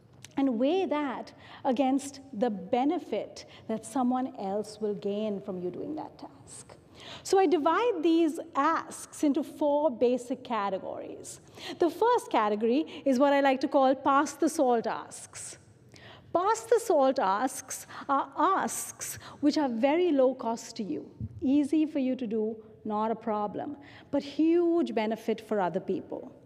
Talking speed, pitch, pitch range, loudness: 145 wpm, 270 Hz, 225-305 Hz, -29 LUFS